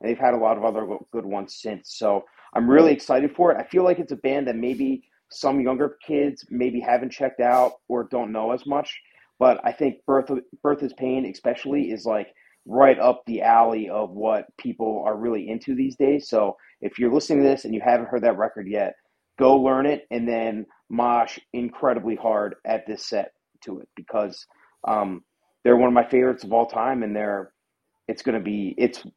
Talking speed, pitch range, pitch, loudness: 210 wpm, 110-130 Hz, 120 Hz, -22 LUFS